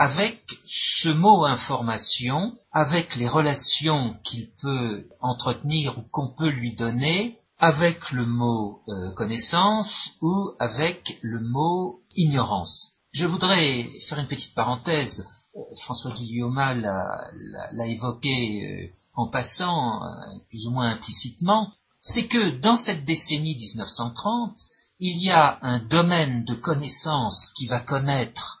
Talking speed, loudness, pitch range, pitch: 130 wpm, -21 LUFS, 120-165 Hz, 140 Hz